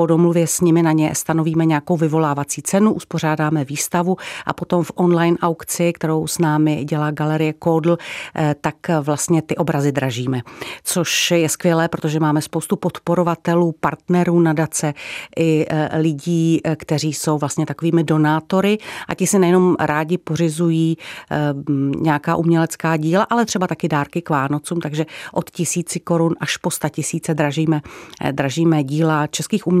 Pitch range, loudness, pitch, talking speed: 155-170 Hz, -18 LUFS, 160 Hz, 145 wpm